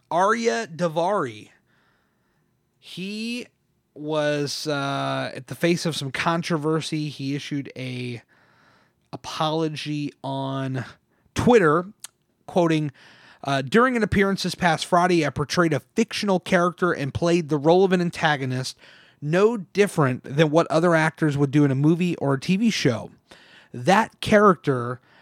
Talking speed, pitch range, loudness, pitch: 130 wpm, 140-180 Hz, -22 LUFS, 160 Hz